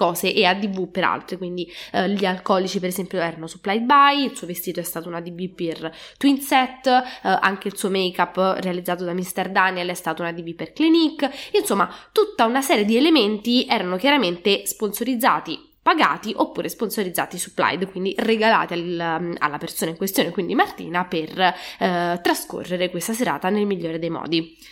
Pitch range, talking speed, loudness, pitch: 175-225 Hz, 170 wpm, -21 LUFS, 185 Hz